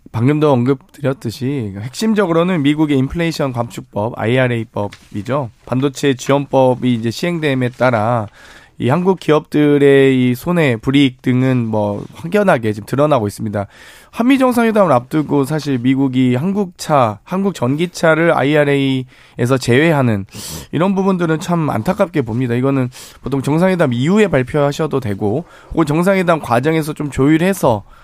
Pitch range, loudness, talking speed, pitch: 125-160 Hz, -15 LUFS, 340 characters per minute, 140 Hz